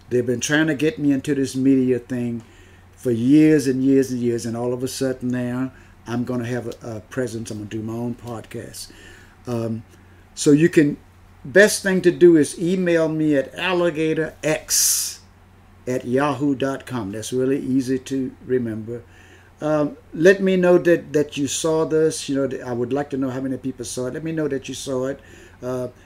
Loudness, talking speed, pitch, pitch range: -20 LUFS, 195 wpm, 130 Hz, 115-145 Hz